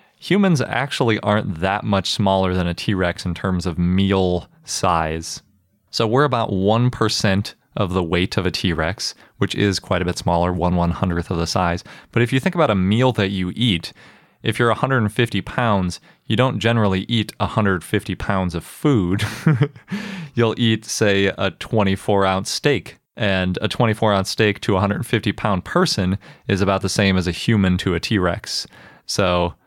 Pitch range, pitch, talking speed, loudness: 95-115 Hz, 100 Hz, 170 wpm, -20 LUFS